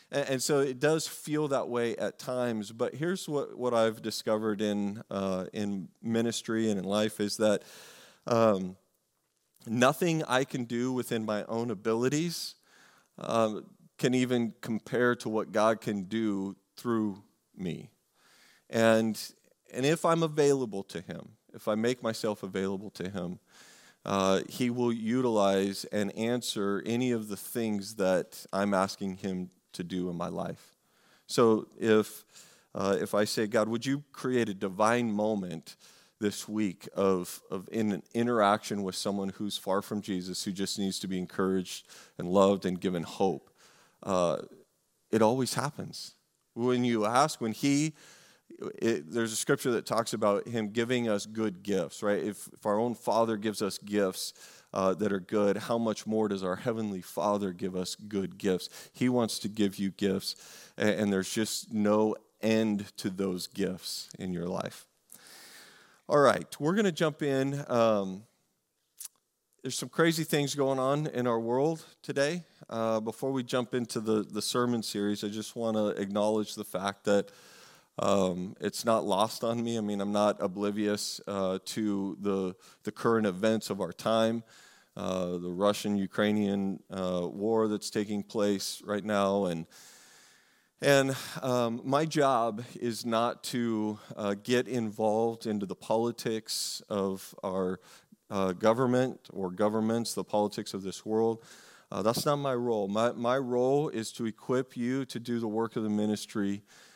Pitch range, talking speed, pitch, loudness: 100-120 Hz, 165 wpm, 110 Hz, -30 LUFS